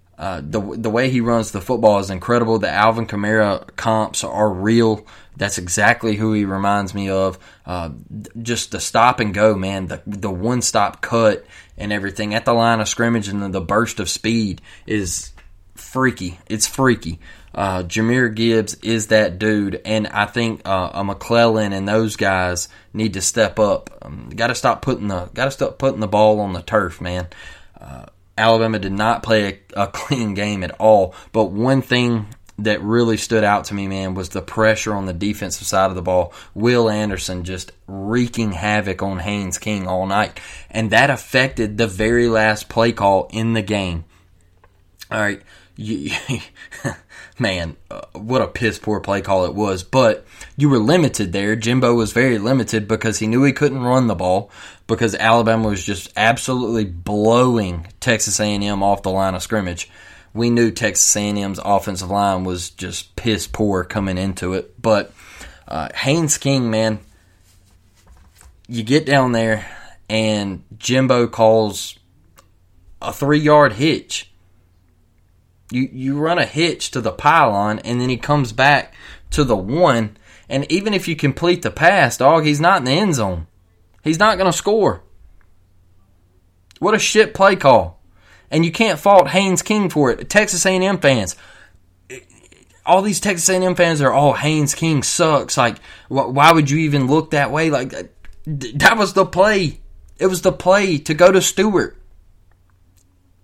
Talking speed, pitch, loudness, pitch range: 170 wpm, 110 Hz, -17 LUFS, 95-125 Hz